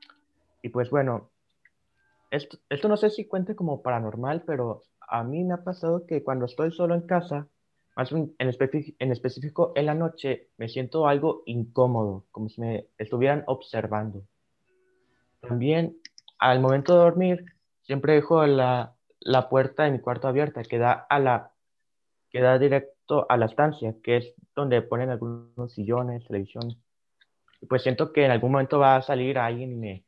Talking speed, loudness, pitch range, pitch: 170 wpm, -25 LUFS, 120-155 Hz, 130 Hz